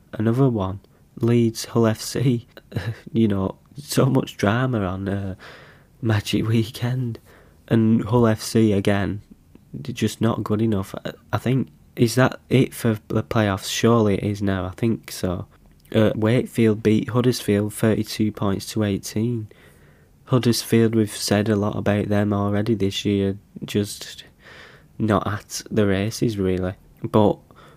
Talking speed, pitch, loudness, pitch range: 135 wpm, 105 Hz, -22 LUFS, 100-115 Hz